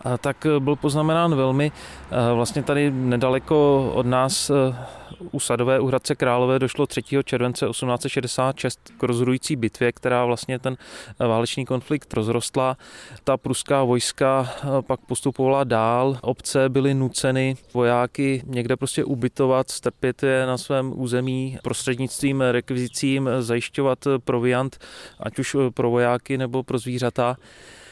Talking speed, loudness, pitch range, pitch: 120 wpm, -22 LUFS, 125-135 Hz, 130 Hz